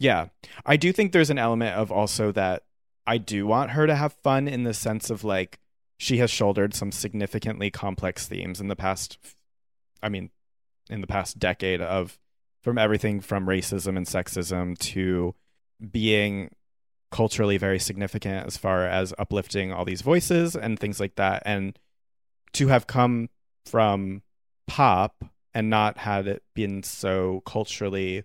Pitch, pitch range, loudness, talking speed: 100 Hz, 95-110 Hz, -25 LUFS, 155 wpm